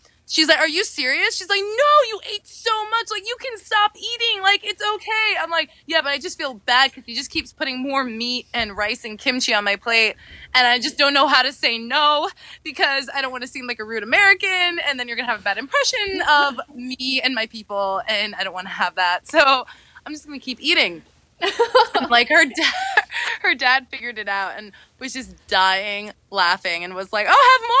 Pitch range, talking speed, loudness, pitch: 235-370 Hz, 225 wpm, -19 LUFS, 275 Hz